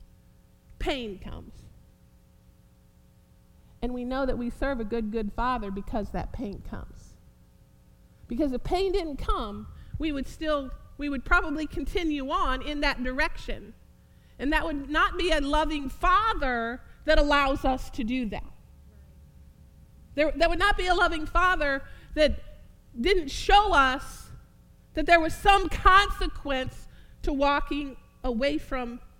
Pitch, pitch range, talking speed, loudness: 285 Hz, 250-330 Hz, 140 wpm, -27 LUFS